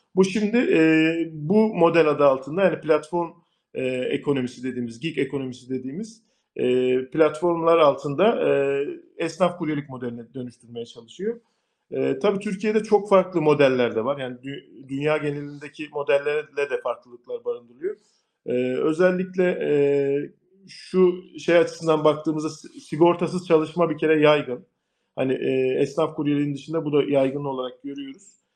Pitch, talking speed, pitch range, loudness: 155 Hz, 130 wpm, 140-180 Hz, -23 LUFS